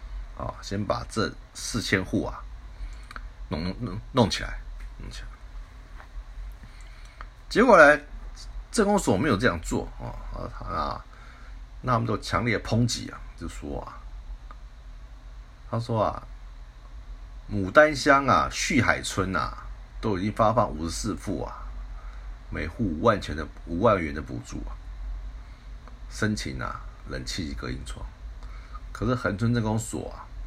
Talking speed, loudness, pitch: 185 characters per minute, -25 LUFS, 100 Hz